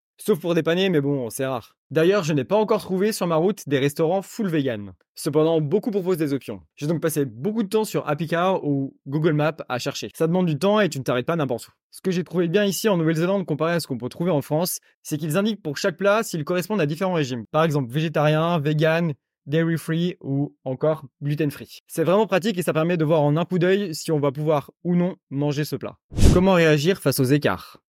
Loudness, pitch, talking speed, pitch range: -22 LUFS, 160 Hz, 245 wpm, 145-185 Hz